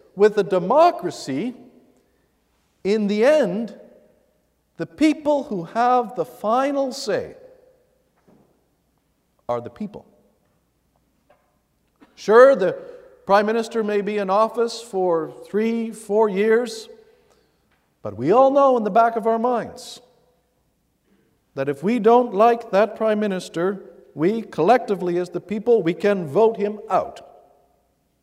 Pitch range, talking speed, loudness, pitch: 205-255 Hz, 120 wpm, -20 LUFS, 225 Hz